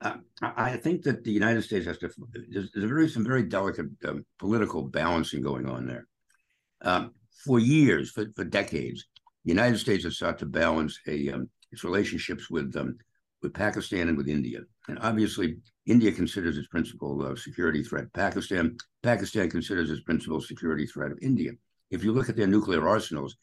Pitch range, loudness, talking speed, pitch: 75-120 Hz, -28 LUFS, 180 wpm, 105 Hz